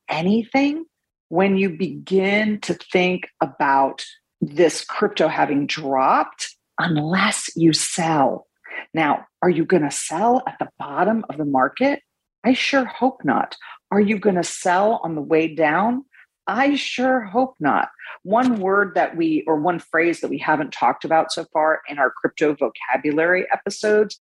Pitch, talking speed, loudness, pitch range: 190 Hz, 155 wpm, -20 LUFS, 160-235 Hz